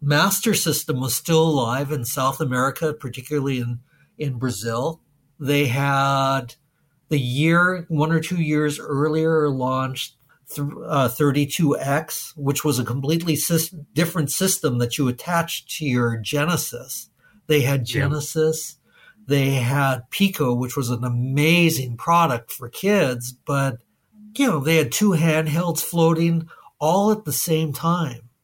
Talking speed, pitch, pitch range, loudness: 135 wpm, 150 Hz, 135-160 Hz, -21 LUFS